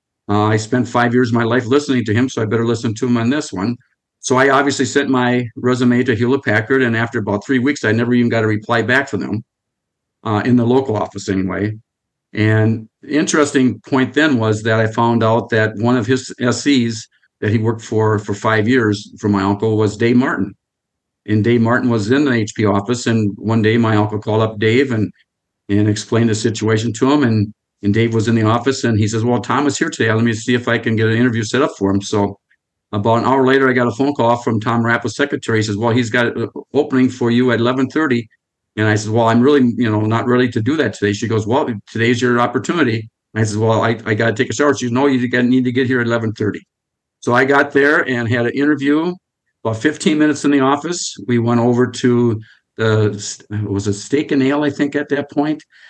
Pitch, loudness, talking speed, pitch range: 120 Hz, -16 LUFS, 240 wpm, 110-130 Hz